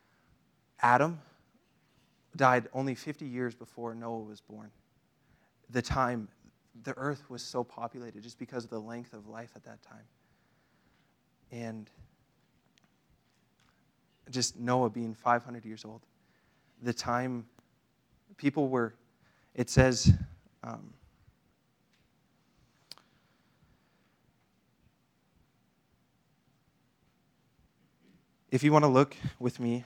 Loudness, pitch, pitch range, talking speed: -31 LUFS, 120 Hz, 115-130 Hz, 95 wpm